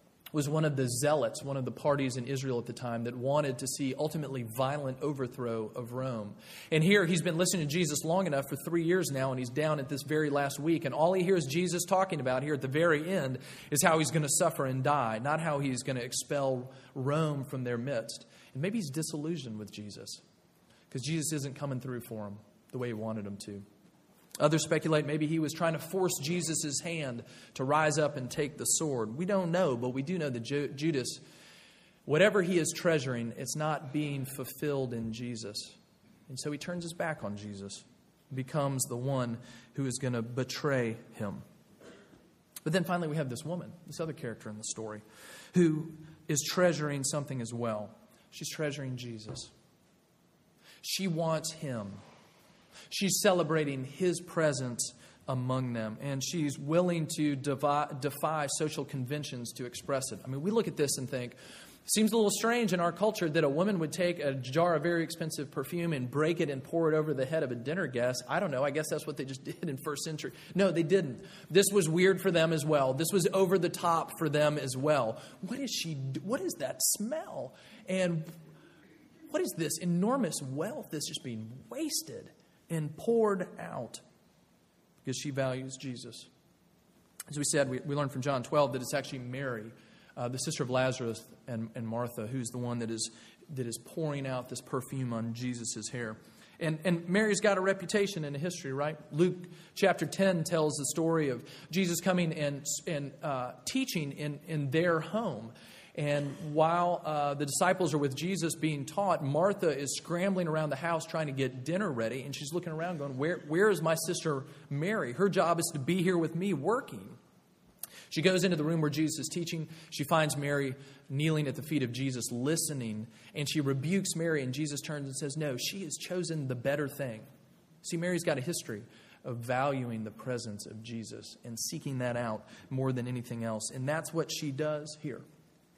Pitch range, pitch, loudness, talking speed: 130-170 Hz, 150 Hz, -32 LUFS, 200 wpm